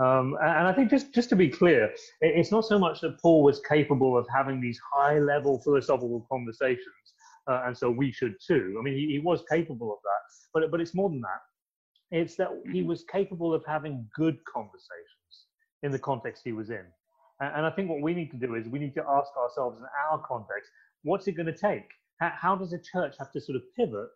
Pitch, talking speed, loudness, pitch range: 160 Hz, 230 wpm, -28 LUFS, 135-190 Hz